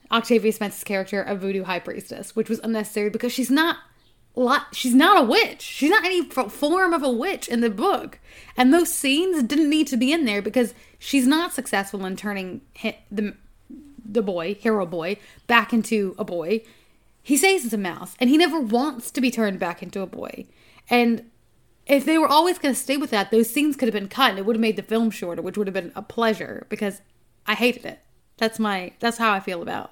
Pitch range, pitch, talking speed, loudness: 205-275 Hz, 230 Hz, 220 wpm, -22 LUFS